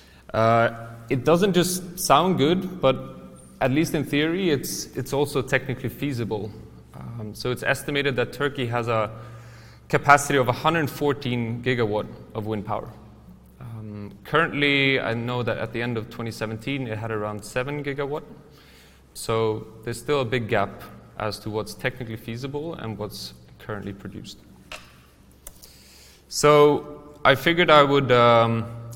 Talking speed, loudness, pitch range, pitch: 140 wpm, -23 LUFS, 110-140 Hz, 120 Hz